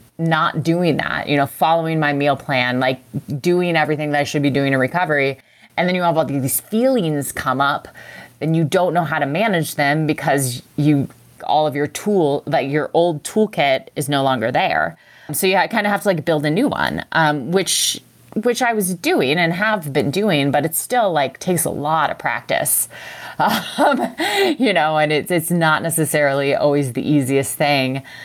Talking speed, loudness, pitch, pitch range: 200 wpm, -18 LUFS, 155 Hz, 140-175 Hz